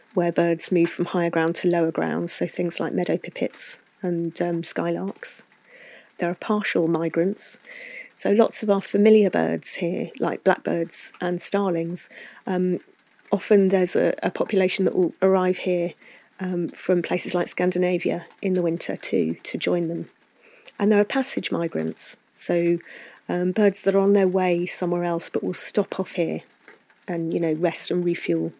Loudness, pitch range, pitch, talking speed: -24 LUFS, 170-195 Hz, 180 Hz, 170 wpm